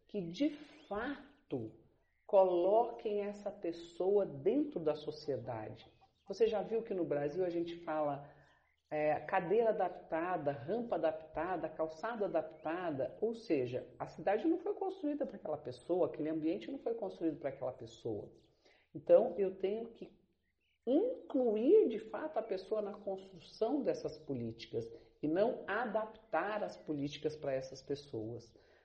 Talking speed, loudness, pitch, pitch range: 135 wpm, -37 LUFS, 190 Hz, 155-225 Hz